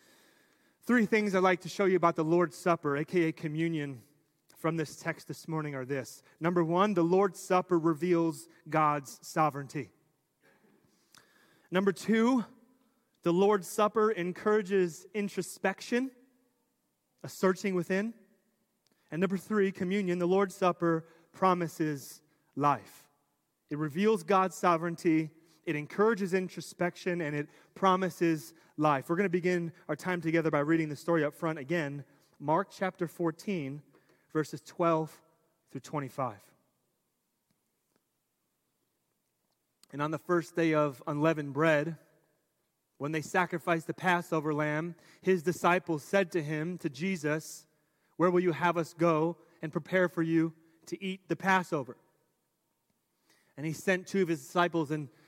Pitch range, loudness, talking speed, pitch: 155-185 Hz, -31 LUFS, 130 wpm, 170 Hz